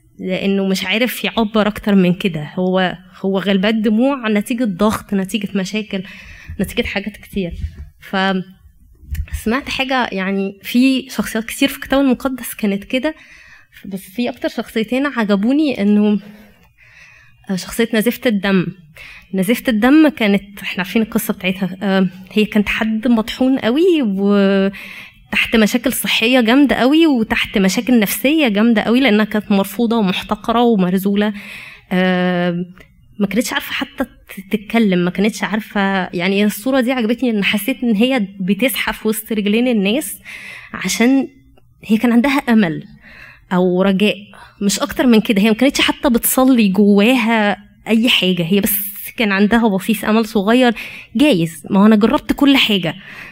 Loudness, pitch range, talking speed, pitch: -16 LUFS, 195-245 Hz, 135 wpm, 215 Hz